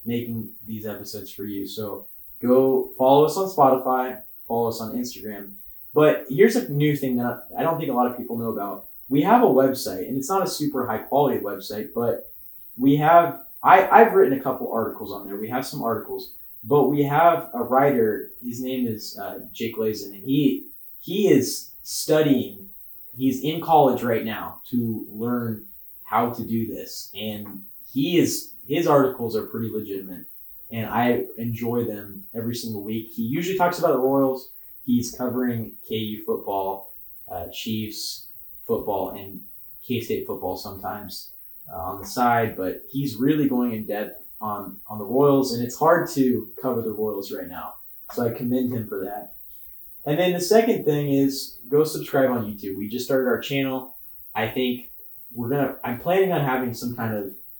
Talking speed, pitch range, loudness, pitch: 180 wpm, 110-140 Hz, -23 LUFS, 125 Hz